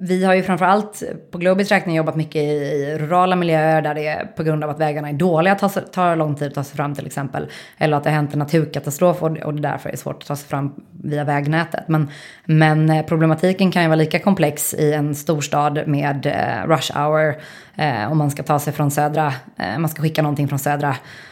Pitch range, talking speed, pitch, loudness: 145-165 Hz, 235 wpm, 155 Hz, -19 LUFS